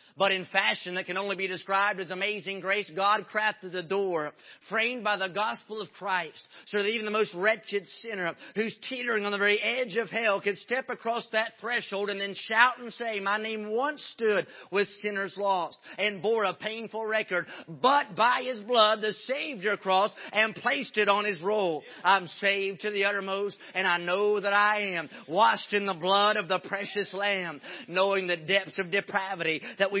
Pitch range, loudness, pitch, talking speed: 190-215 Hz, -28 LUFS, 200 Hz, 195 wpm